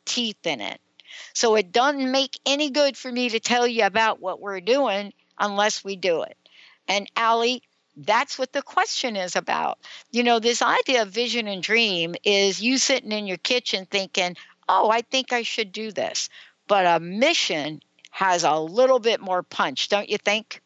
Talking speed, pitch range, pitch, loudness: 185 wpm, 195-250 Hz, 225 Hz, -22 LUFS